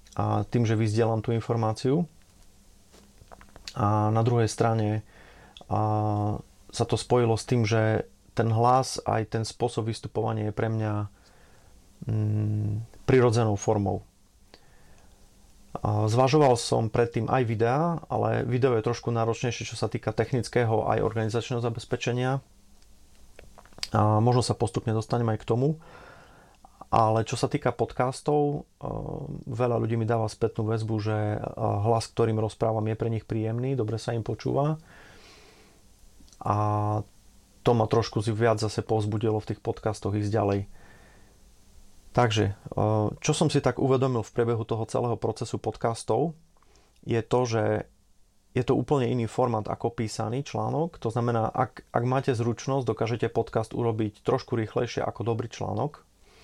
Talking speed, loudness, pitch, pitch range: 135 wpm, -27 LUFS, 115 Hz, 105-120 Hz